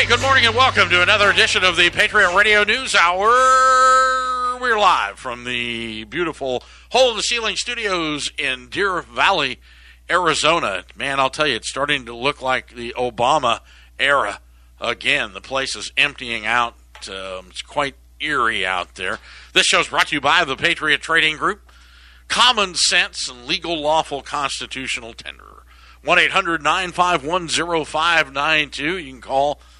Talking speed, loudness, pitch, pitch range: 165 wpm, -17 LUFS, 145 Hz, 120-185 Hz